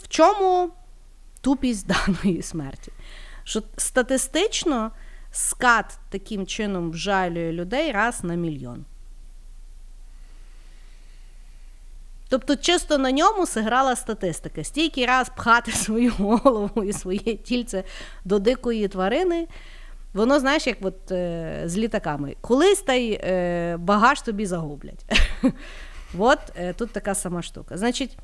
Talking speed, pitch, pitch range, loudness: 110 wpm, 215 Hz, 180-260 Hz, -23 LUFS